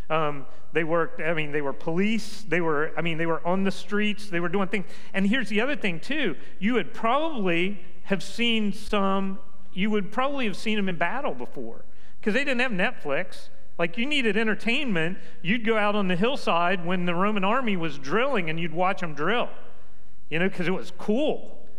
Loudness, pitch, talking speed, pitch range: -26 LUFS, 195 Hz, 205 wpm, 170-215 Hz